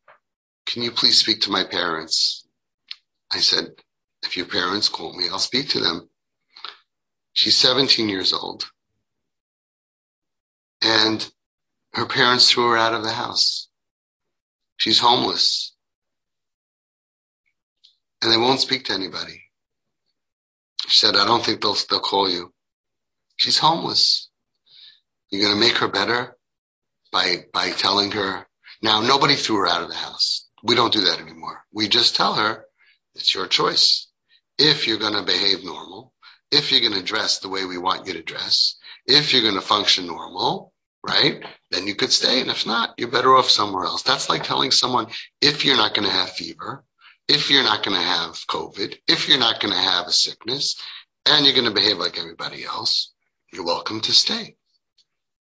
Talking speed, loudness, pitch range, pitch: 165 wpm, -18 LUFS, 110-150 Hz, 120 Hz